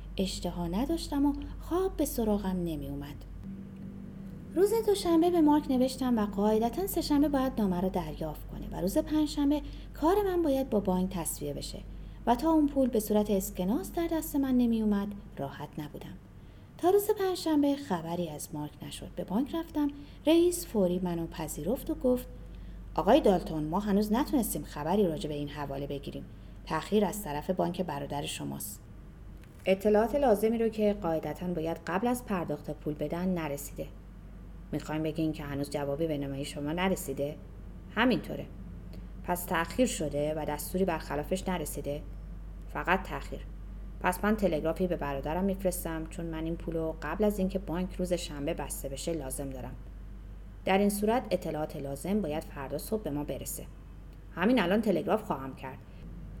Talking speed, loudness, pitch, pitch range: 155 wpm, -31 LUFS, 180 Hz, 150-230 Hz